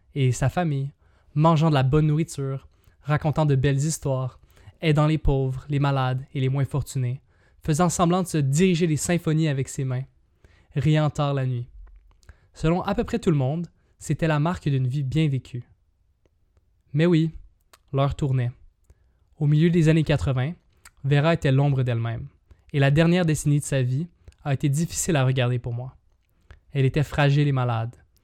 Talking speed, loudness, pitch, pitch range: 170 wpm, -23 LUFS, 140 Hz, 125-155 Hz